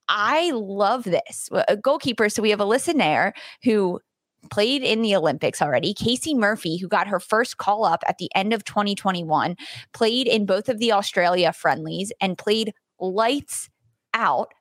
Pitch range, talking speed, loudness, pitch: 185-230 Hz, 165 wpm, -22 LUFS, 210 Hz